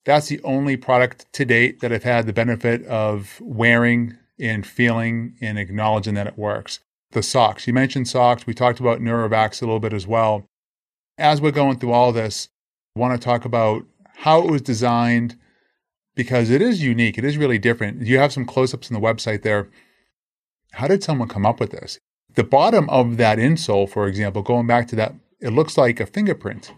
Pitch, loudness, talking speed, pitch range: 120 Hz, -19 LUFS, 200 wpm, 110-130 Hz